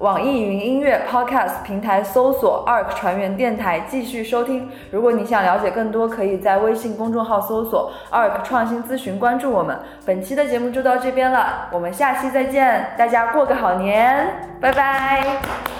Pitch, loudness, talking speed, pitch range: 240 Hz, -19 LUFS, 305 characters per minute, 205-260 Hz